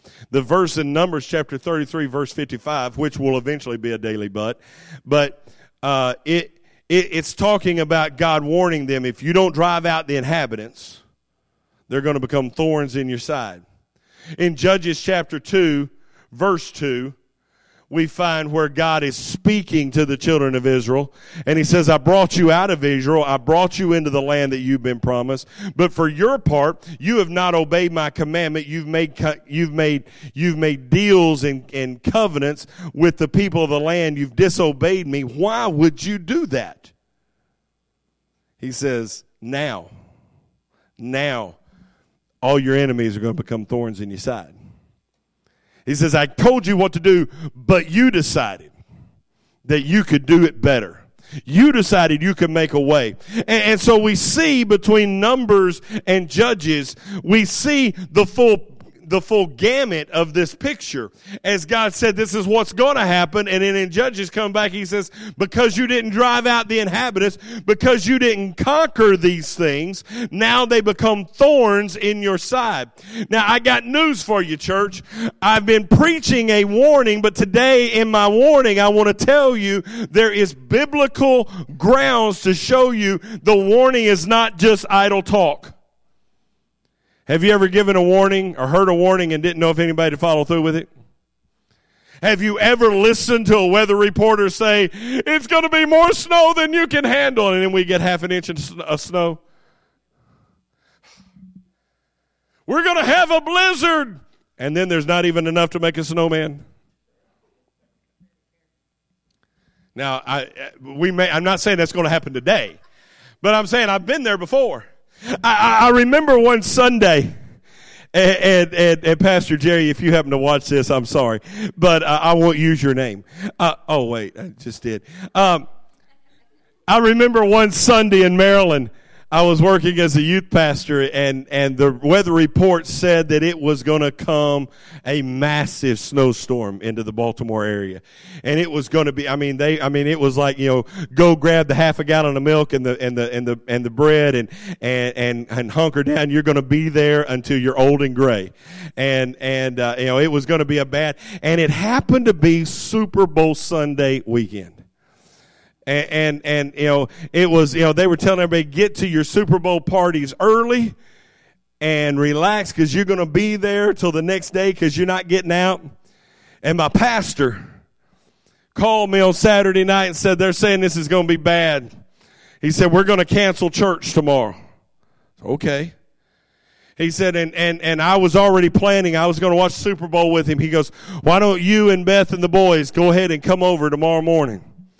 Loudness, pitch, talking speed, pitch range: -16 LUFS, 170 Hz, 180 wpm, 145-200 Hz